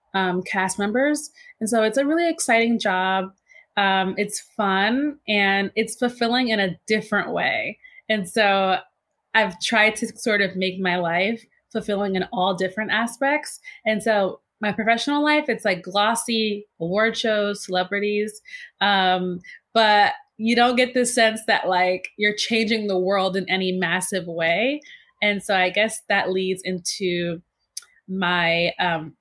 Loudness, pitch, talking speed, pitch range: -21 LUFS, 210 Hz, 150 wpm, 190-230 Hz